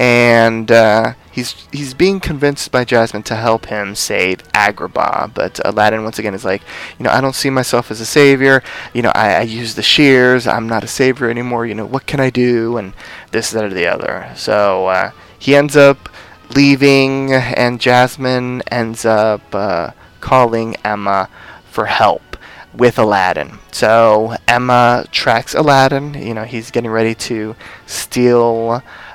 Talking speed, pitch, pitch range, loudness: 165 wpm, 120 Hz, 110-130 Hz, -13 LUFS